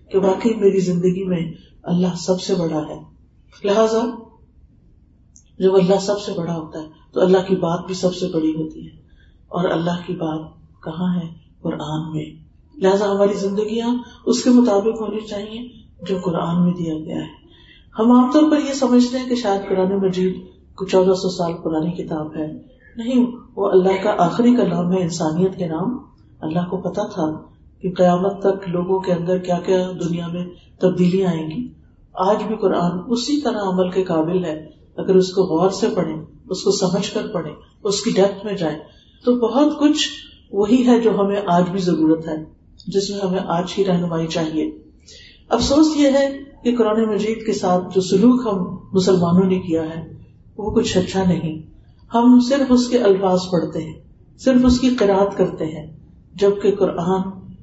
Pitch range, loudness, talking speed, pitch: 170-210 Hz, -19 LUFS, 180 wpm, 190 Hz